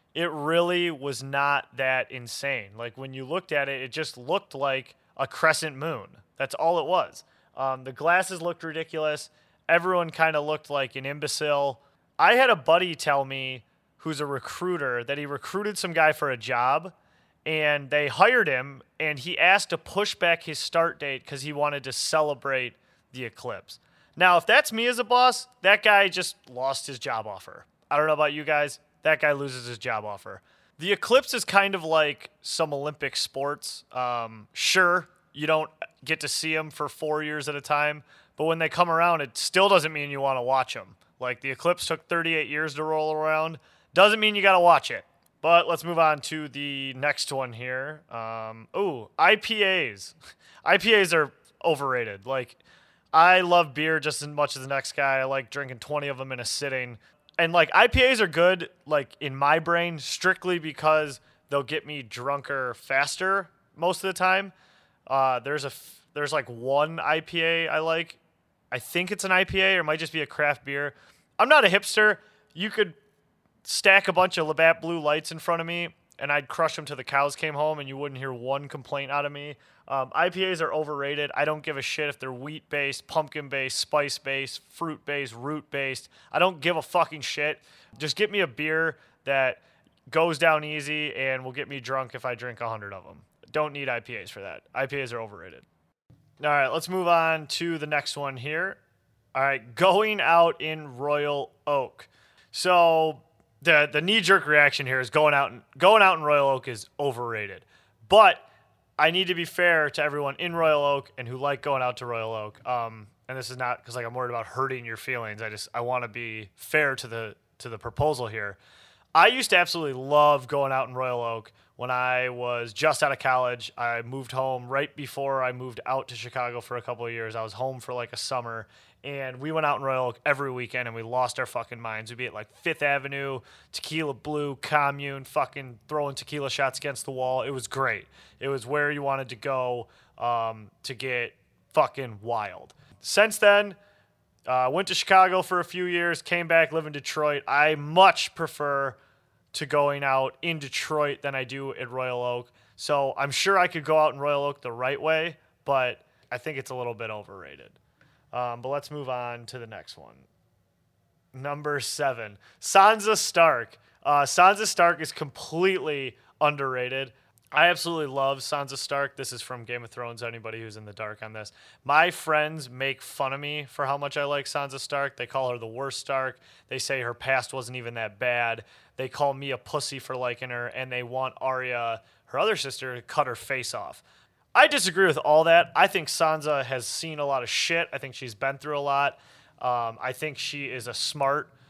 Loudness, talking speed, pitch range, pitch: -25 LUFS, 205 wpm, 130-160 Hz, 145 Hz